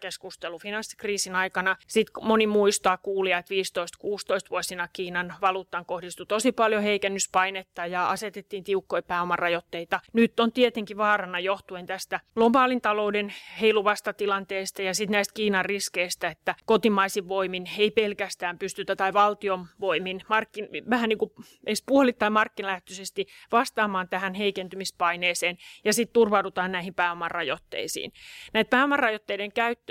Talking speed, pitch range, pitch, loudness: 120 wpm, 185-215 Hz, 200 Hz, -26 LUFS